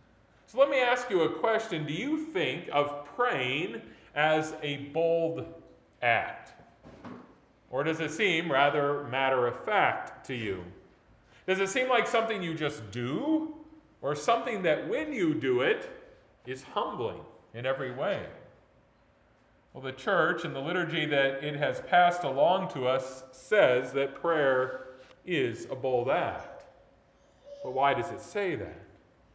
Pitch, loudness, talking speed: 165 Hz, -29 LUFS, 145 wpm